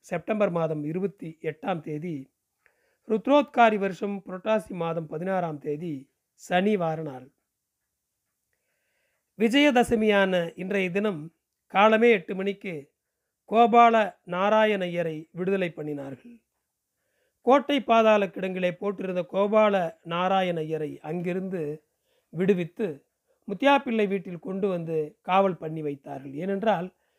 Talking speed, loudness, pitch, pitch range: 90 wpm, -25 LUFS, 190 Hz, 165-215 Hz